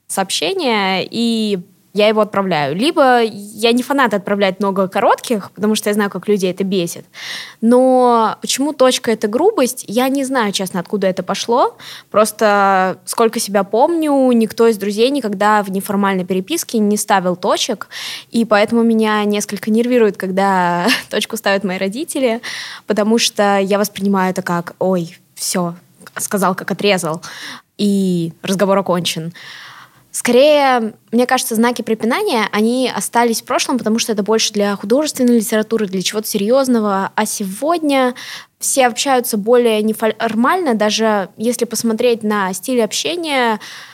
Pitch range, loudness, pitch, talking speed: 195-240 Hz, -15 LUFS, 215 Hz, 140 wpm